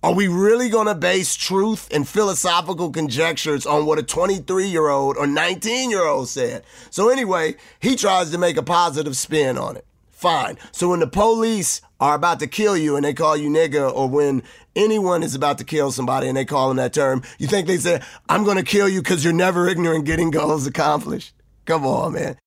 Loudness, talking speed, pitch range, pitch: -19 LUFS, 210 wpm, 150-190 Hz, 170 Hz